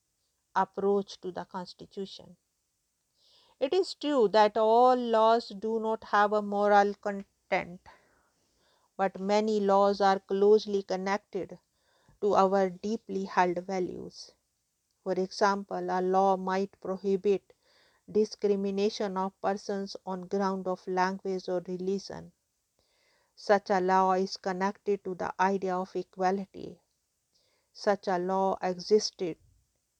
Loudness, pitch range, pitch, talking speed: -29 LUFS, 185-210 Hz, 195 Hz, 110 wpm